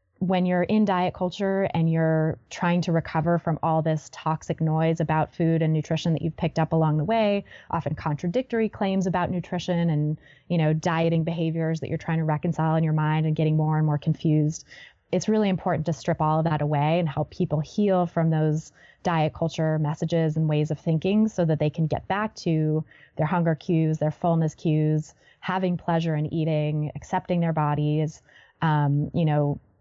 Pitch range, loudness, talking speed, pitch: 155-175 Hz, -25 LUFS, 190 wpm, 160 Hz